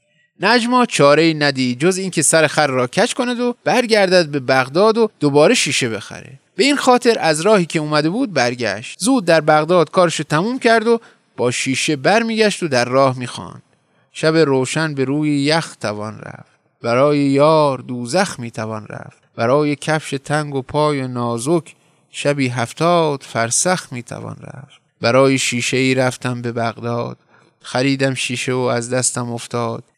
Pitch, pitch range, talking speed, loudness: 145 Hz, 125-170 Hz, 160 wpm, -16 LUFS